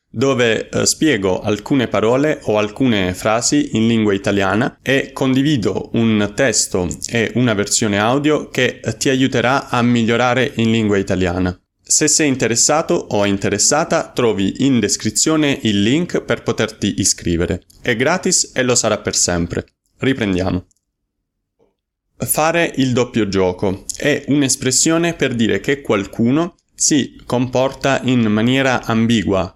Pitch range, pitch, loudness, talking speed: 100-135 Hz, 115 Hz, -16 LUFS, 125 wpm